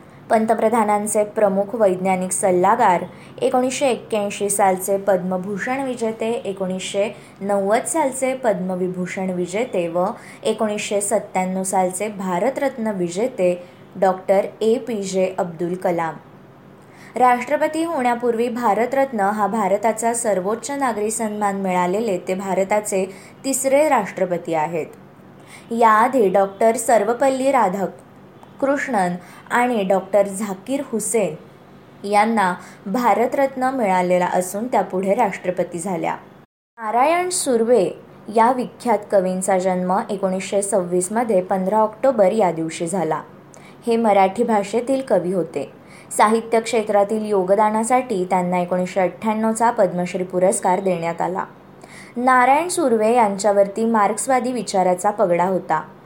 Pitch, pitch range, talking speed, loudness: 205 Hz, 185-230 Hz, 95 wpm, -19 LUFS